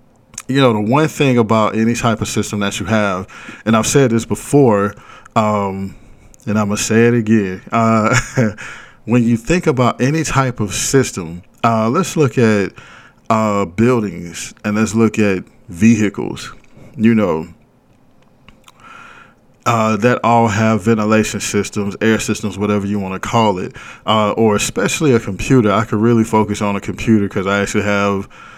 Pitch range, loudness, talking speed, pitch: 105-120 Hz, -15 LUFS, 165 wpm, 110 Hz